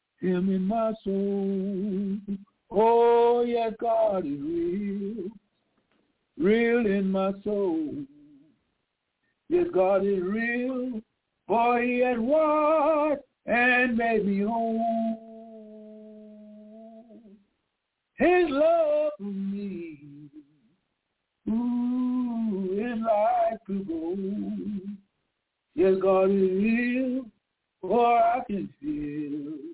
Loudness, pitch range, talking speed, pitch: -26 LUFS, 200-250 Hz, 85 wpm, 225 Hz